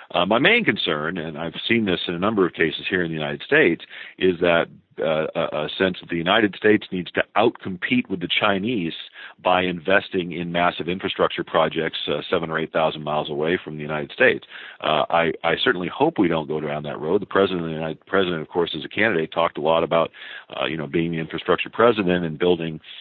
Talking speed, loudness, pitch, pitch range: 225 wpm, -22 LUFS, 85 Hz, 80-90 Hz